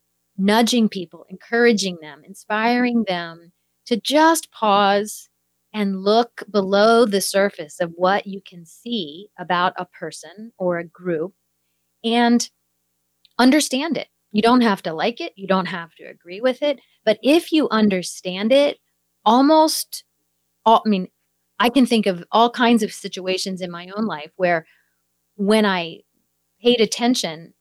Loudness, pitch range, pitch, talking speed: -19 LUFS, 170-235 Hz, 195 Hz, 145 wpm